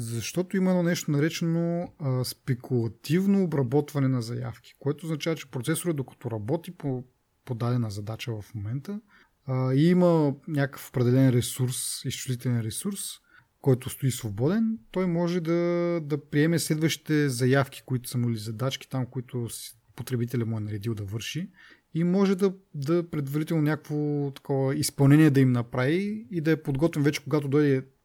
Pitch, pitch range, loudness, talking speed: 140 Hz, 125-165 Hz, -27 LUFS, 150 wpm